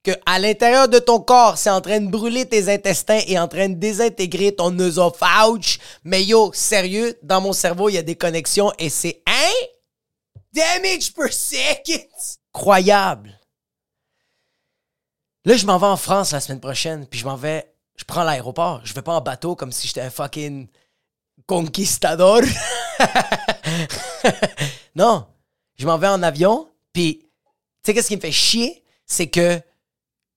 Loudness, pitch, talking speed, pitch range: -18 LUFS, 190 Hz, 160 wpm, 160-220 Hz